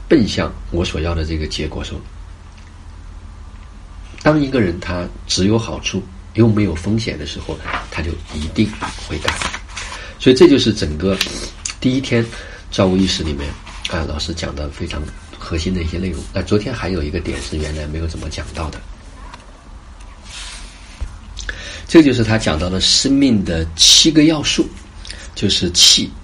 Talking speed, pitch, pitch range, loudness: 225 characters per minute, 85 Hz, 80-95 Hz, -16 LUFS